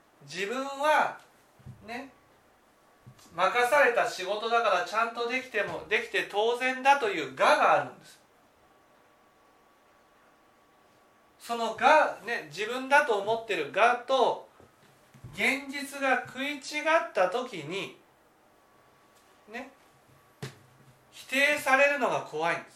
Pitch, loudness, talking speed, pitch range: 245 Hz, -27 LUFS, 205 characters per minute, 220-275 Hz